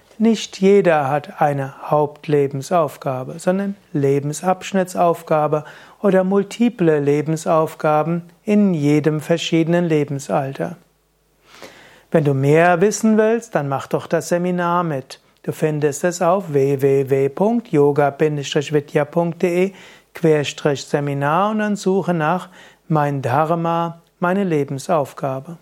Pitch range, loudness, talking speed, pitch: 145-185 Hz, -18 LUFS, 95 wpm, 160 Hz